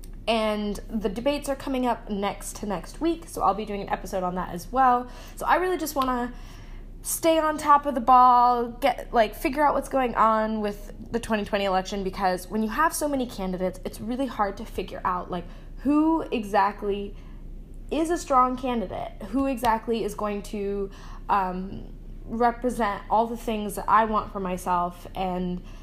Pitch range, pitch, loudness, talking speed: 200-255 Hz, 220 Hz, -25 LUFS, 185 wpm